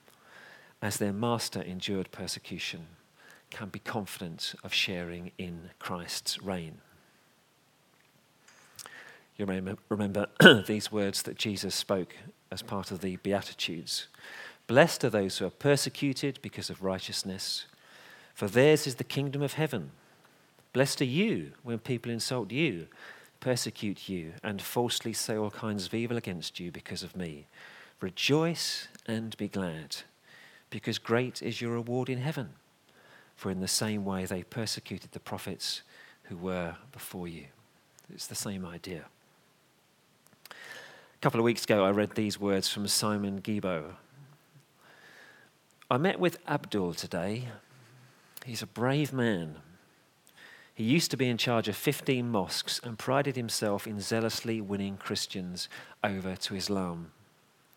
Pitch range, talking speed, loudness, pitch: 95-125 Hz, 135 wpm, -31 LUFS, 105 Hz